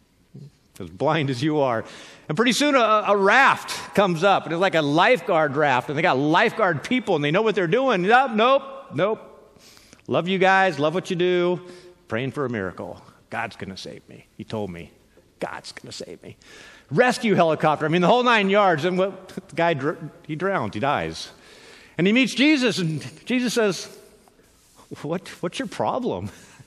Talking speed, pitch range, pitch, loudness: 185 wpm, 150-210 Hz, 180 Hz, -21 LUFS